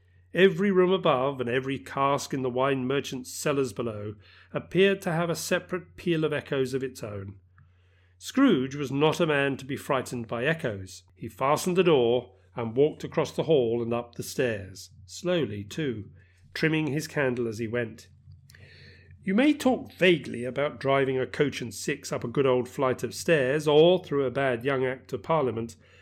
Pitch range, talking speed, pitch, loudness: 115-150 Hz, 180 wpm, 130 Hz, -27 LUFS